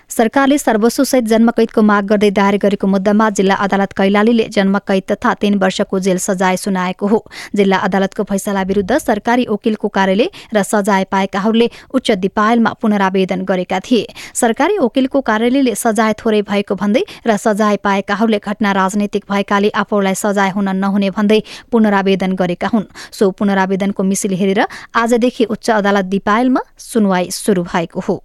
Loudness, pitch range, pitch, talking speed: -14 LUFS, 195-225 Hz, 205 Hz, 145 wpm